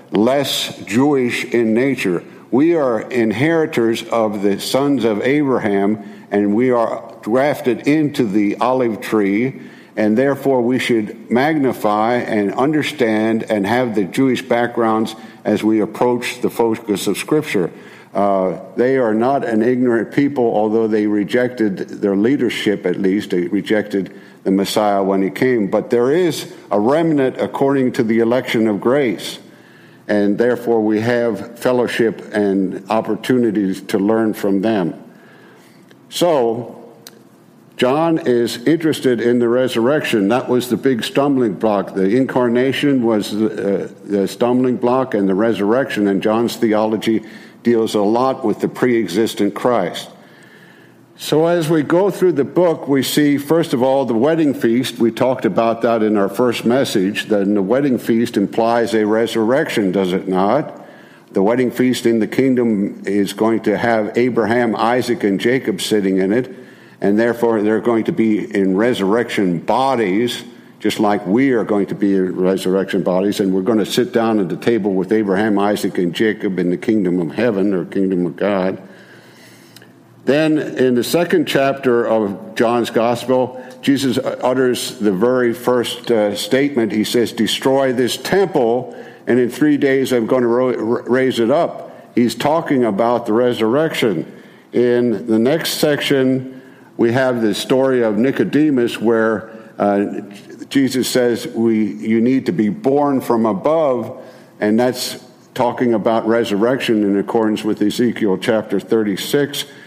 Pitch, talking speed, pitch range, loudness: 115 Hz, 150 wpm, 105-125 Hz, -17 LUFS